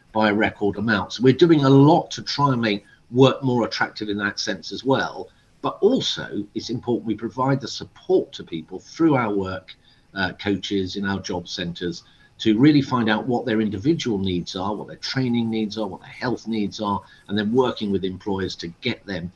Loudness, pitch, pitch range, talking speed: -22 LUFS, 110 Hz, 100-125 Hz, 200 wpm